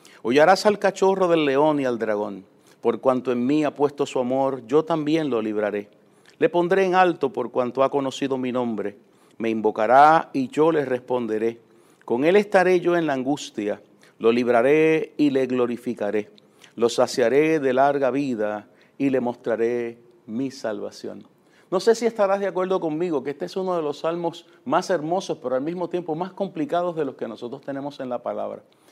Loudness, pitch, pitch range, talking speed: -22 LUFS, 140 Hz, 120-170 Hz, 185 wpm